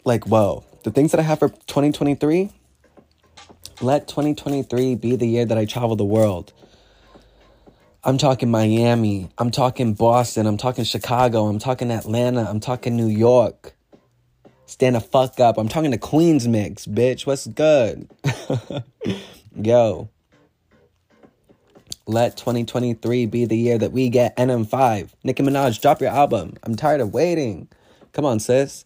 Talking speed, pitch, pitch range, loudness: 145 wpm, 120 Hz, 110-130 Hz, -20 LUFS